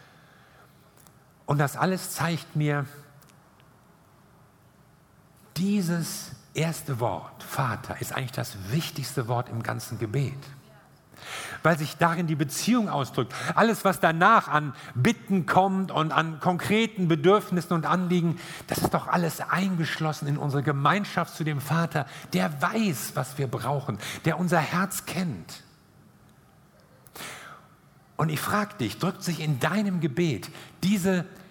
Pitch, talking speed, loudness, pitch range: 160 Hz, 125 wpm, -26 LUFS, 145-180 Hz